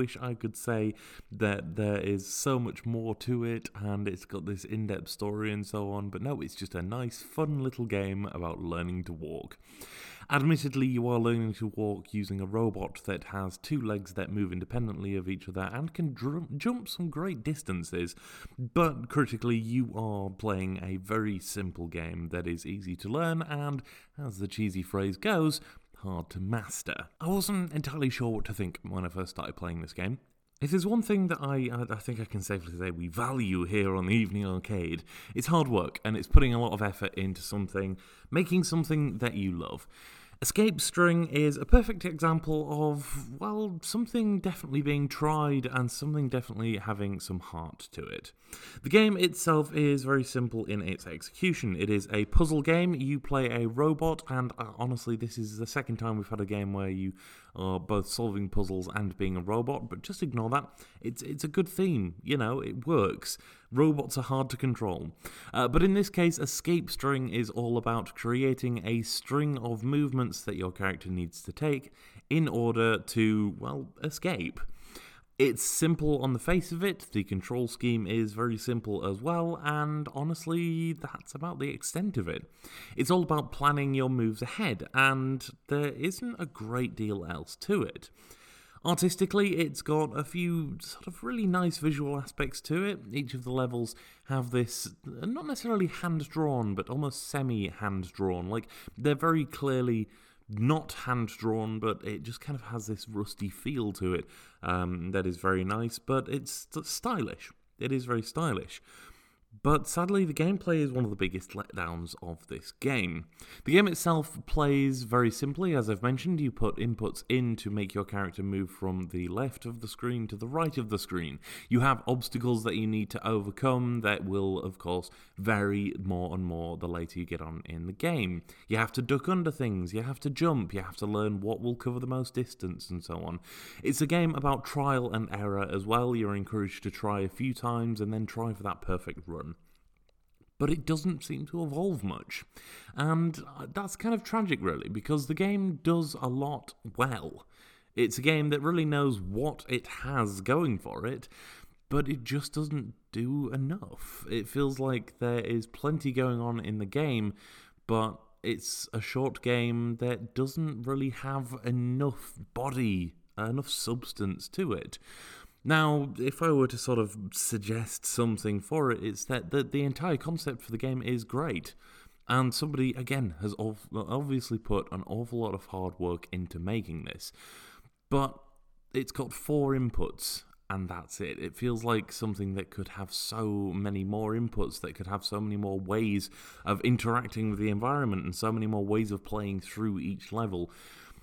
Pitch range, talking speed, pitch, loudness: 100-145 Hz, 185 wpm, 115 Hz, -32 LUFS